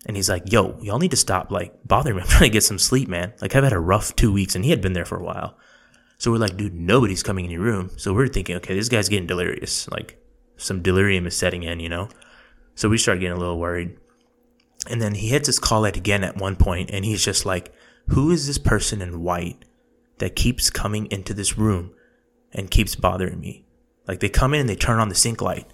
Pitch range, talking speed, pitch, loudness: 90-115 Hz, 250 wpm, 100 Hz, -21 LUFS